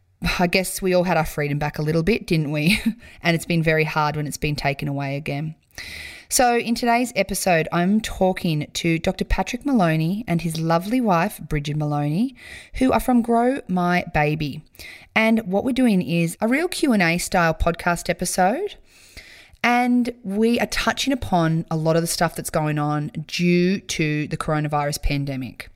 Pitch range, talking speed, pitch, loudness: 155-215 Hz, 175 wpm, 175 Hz, -21 LUFS